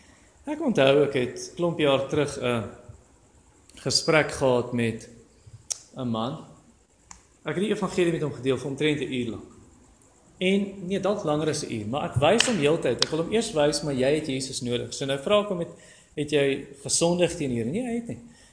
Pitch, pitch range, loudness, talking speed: 145 Hz, 125-170 Hz, -25 LUFS, 210 wpm